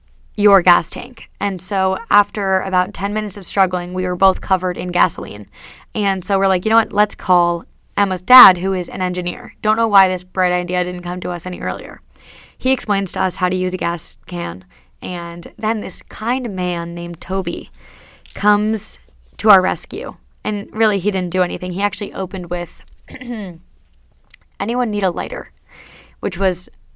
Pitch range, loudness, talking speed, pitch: 175-205 Hz, -17 LUFS, 180 wpm, 185 Hz